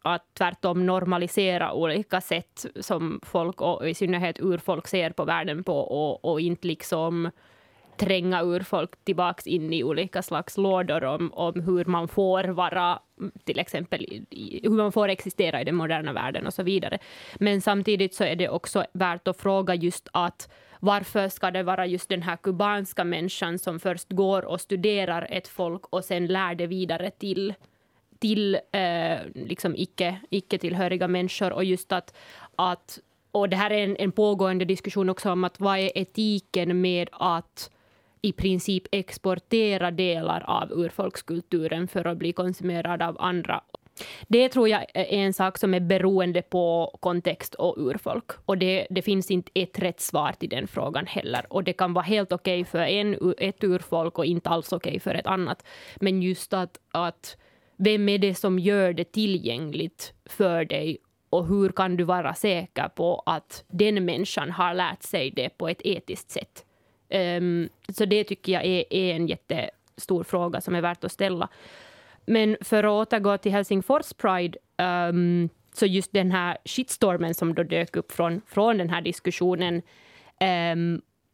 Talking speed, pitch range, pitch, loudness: 170 wpm, 175-195 Hz, 185 Hz, -26 LUFS